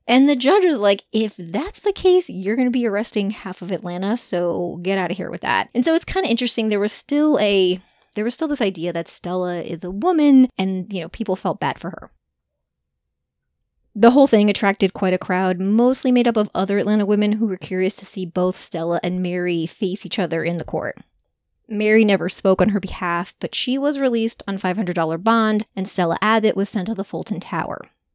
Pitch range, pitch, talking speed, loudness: 180-225 Hz, 195 Hz, 220 wpm, -20 LUFS